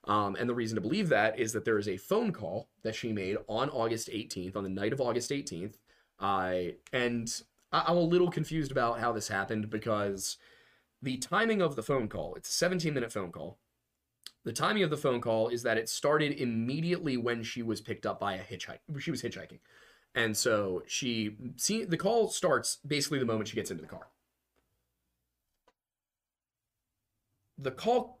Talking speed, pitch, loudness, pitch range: 185 wpm, 115 Hz, -32 LUFS, 105-145 Hz